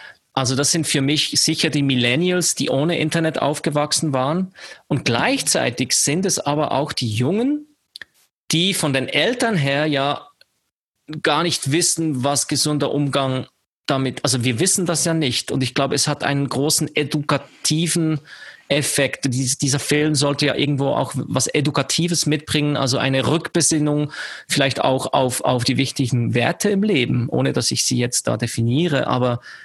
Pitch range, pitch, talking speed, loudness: 135-160 Hz, 145 Hz, 160 wpm, -19 LUFS